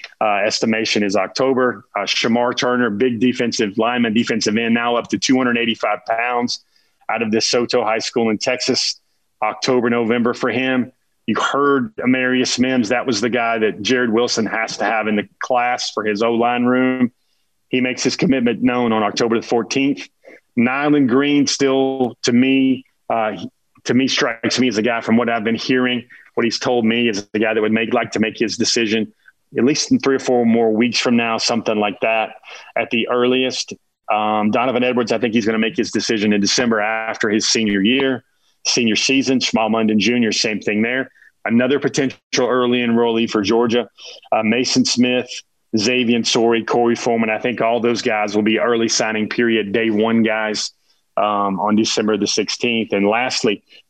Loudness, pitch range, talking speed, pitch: -17 LUFS, 110-125 Hz, 185 wpm, 120 Hz